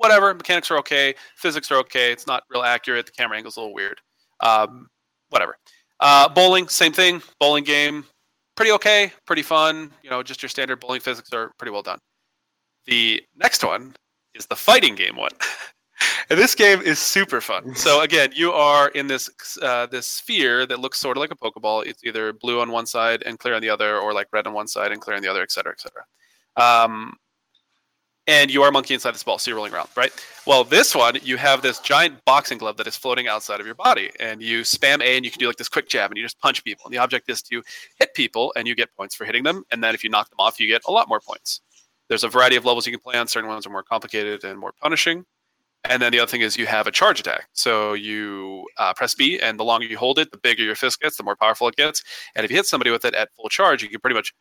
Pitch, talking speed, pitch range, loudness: 125 Hz, 260 wpm, 110-145 Hz, -19 LUFS